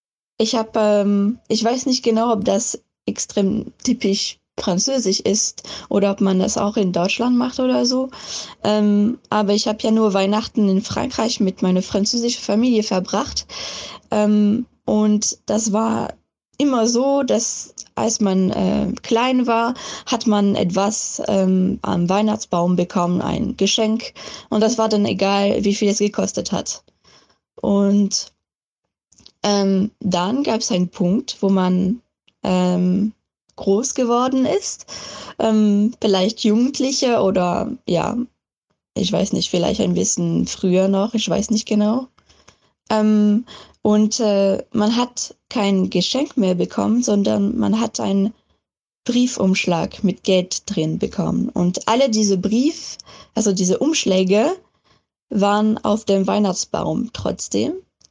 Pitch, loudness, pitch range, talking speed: 210 Hz, -19 LUFS, 195-230 Hz, 130 wpm